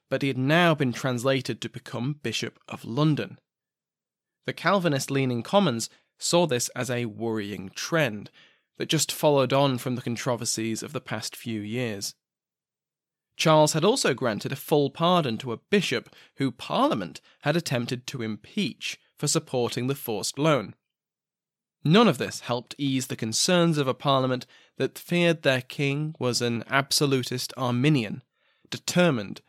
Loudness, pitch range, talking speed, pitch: -26 LUFS, 120-150 Hz, 150 wpm, 130 Hz